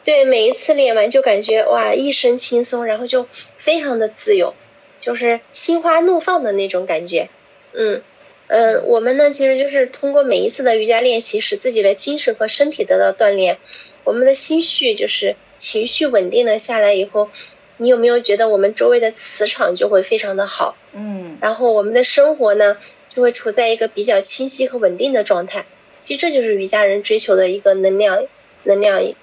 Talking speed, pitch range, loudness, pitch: 295 characters per minute, 210-290 Hz, -15 LUFS, 240 Hz